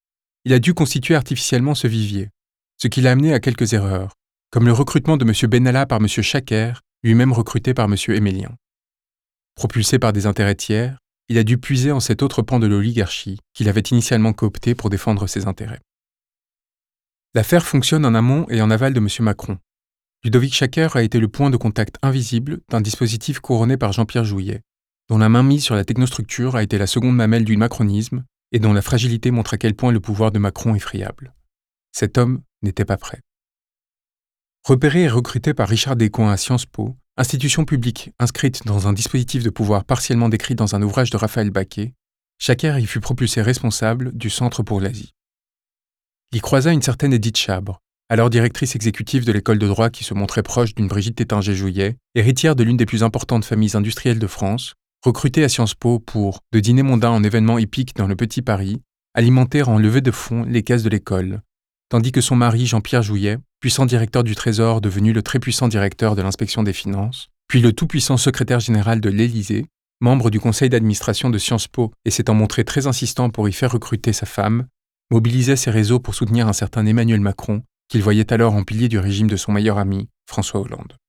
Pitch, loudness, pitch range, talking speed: 115 Hz, -18 LUFS, 105-125 Hz, 195 wpm